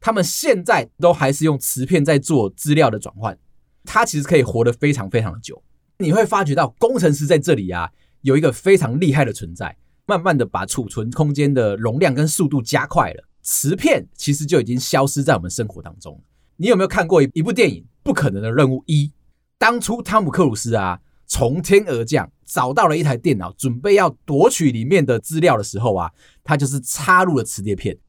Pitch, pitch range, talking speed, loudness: 140 Hz, 115-160 Hz, 310 characters per minute, -18 LUFS